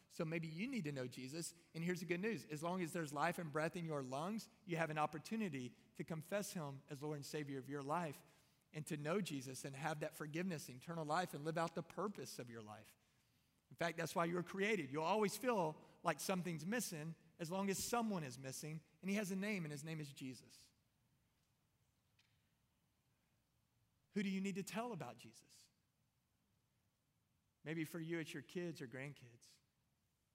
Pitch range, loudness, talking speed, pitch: 135-175 Hz, -45 LUFS, 195 wpm, 160 Hz